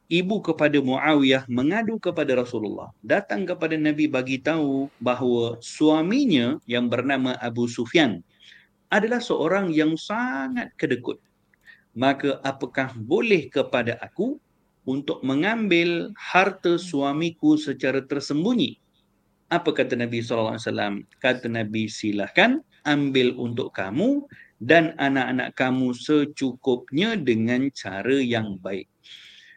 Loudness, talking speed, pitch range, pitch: -23 LUFS, 110 wpm, 120-160 Hz, 135 Hz